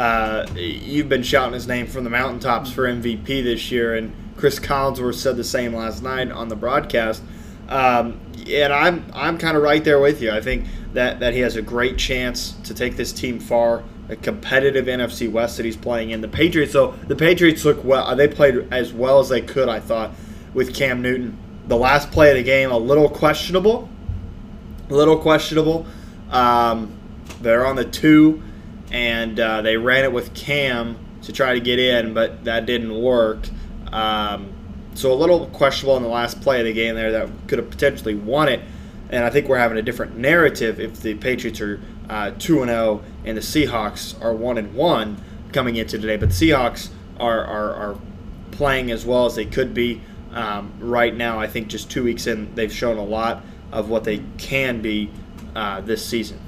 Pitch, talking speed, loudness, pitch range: 120 Hz, 195 wpm, -19 LUFS, 110-135 Hz